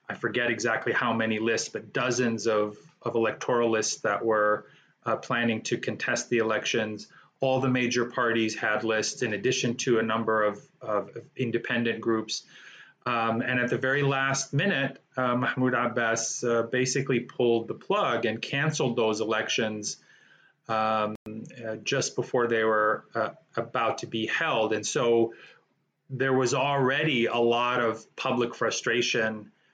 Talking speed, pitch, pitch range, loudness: 150 wpm, 115 Hz, 110-125 Hz, -27 LUFS